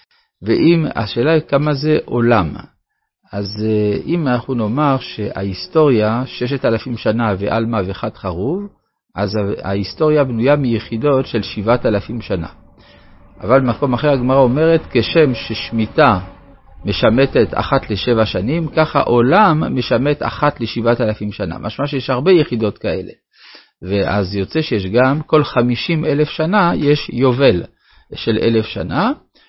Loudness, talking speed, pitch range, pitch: -16 LUFS, 125 wpm, 105-145 Hz, 120 Hz